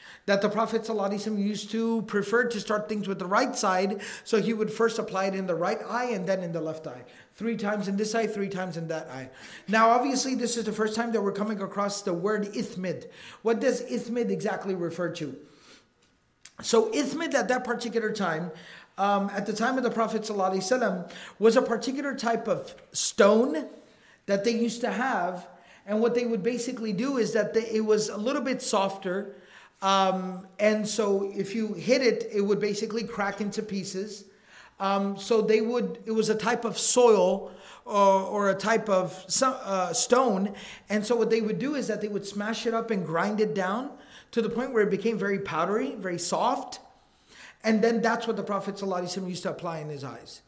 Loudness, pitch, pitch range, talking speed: -27 LUFS, 215 Hz, 195-230 Hz, 200 wpm